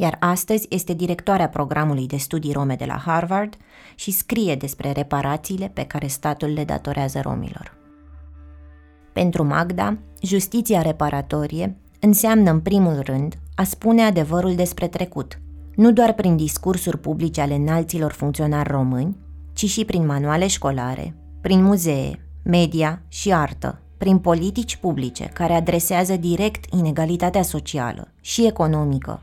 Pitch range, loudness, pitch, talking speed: 140-185 Hz, -21 LUFS, 160 Hz, 130 wpm